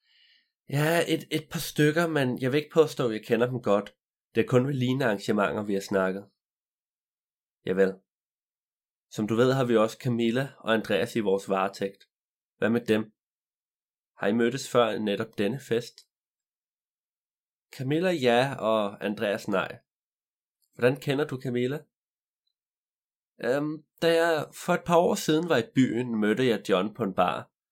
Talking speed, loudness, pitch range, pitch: 160 wpm, -27 LUFS, 110-150 Hz, 125 Hz